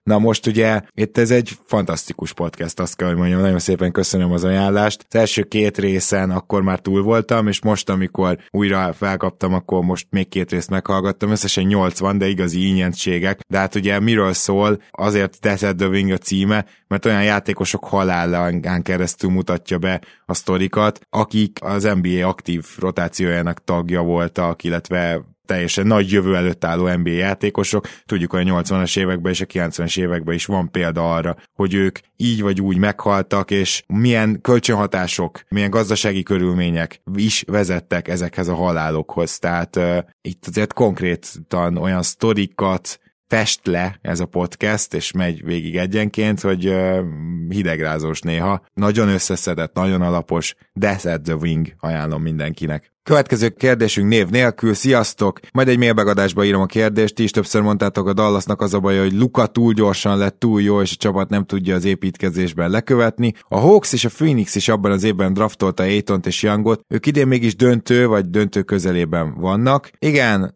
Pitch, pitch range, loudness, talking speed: 95 Hz, 90-105 Hz, -18 LUFS, 165 wpm